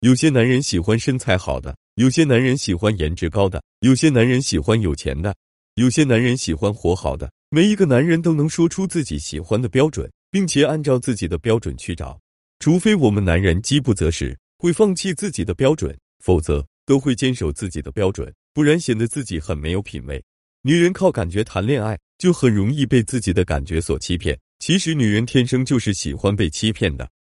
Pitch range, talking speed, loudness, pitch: 85-140 Hz, 310 characters per minute, -19 LUFS, 110 Hz